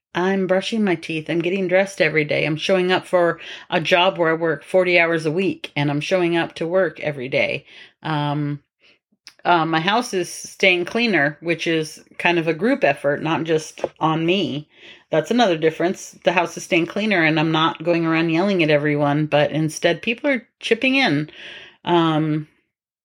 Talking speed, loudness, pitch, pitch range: 185 wpm, -19 LUFS, 170 Hz, 155-185 Hz